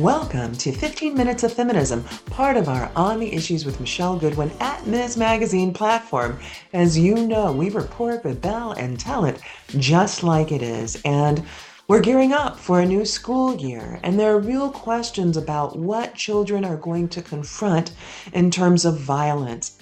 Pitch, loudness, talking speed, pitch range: 180 Hz, -21 LUFS, 175 wpm, 145-225 Hz